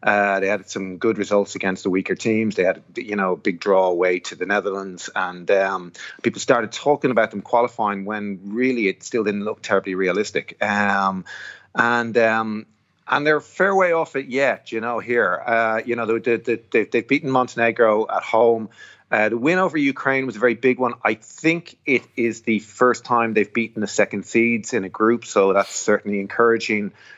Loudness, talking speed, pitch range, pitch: -20 LUFS, 200 wpm, 100-120 Hz, 115 Hz